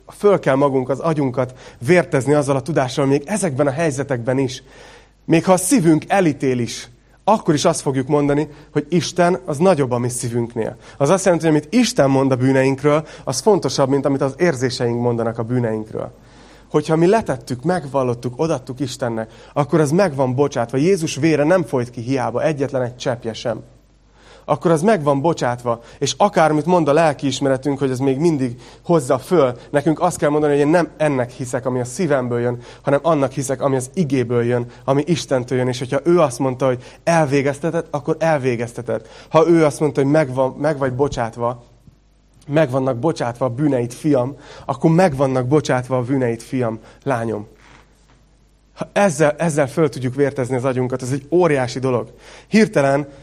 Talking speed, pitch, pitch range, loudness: 175 wpm, 140 Hz, 130-160 Hz, -18 LUFS